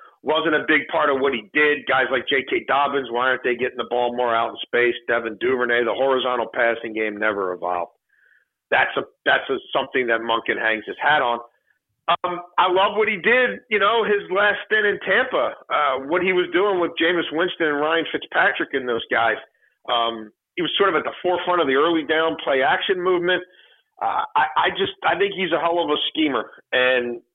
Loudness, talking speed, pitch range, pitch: -20 LUFS, 210 wpm, 125-190 Hz, 165 Hz